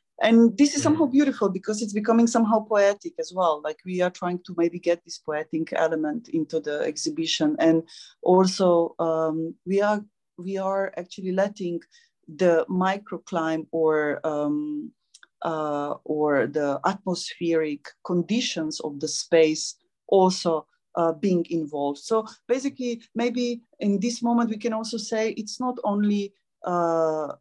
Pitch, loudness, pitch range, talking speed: 185 Hz, -24 LUFS, 160-230 Hz, 140 wpm